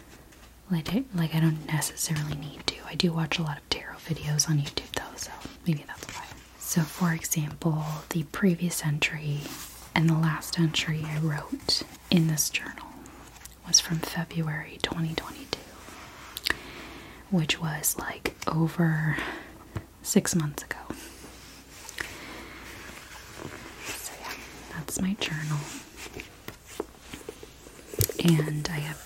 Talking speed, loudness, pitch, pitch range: 115 wpm, -29 LUFS, 160 Hz, 155-170 Hz